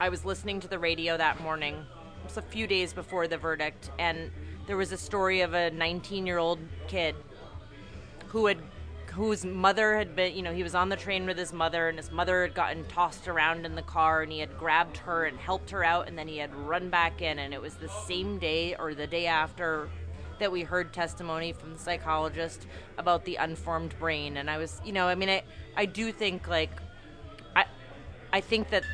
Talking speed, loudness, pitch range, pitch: 220 wpm, -30 LUFS, 150-185 Hz, 165 Hz